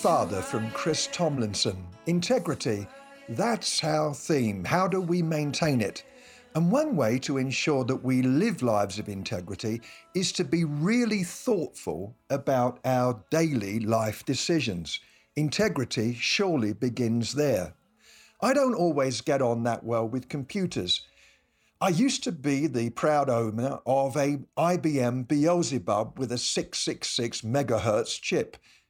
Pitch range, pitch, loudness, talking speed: 115-165 Hz, 135 Hz, -27 LUFS, 130 wpm